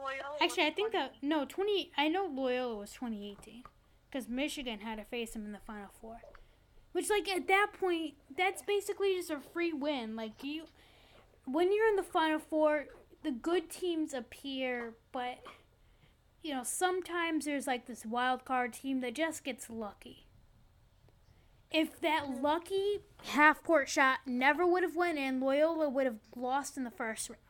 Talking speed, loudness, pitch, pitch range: 170 wpm, -34 LUFS, 290 Hz, 250-340 Hz